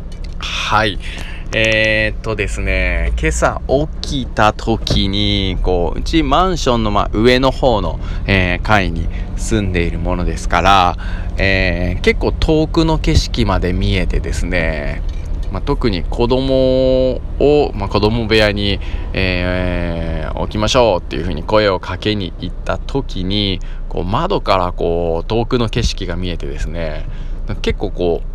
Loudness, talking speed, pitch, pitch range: -16 LUFS, 270 characters per minute, 95 Hz, 85-110 Hz